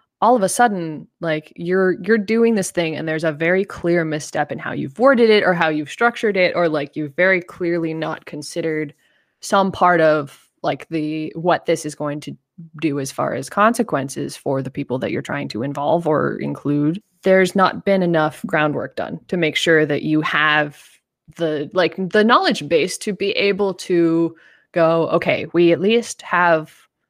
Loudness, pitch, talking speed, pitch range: -19 LUFS, 170 Hz, 190 wpm, 155-190 Hz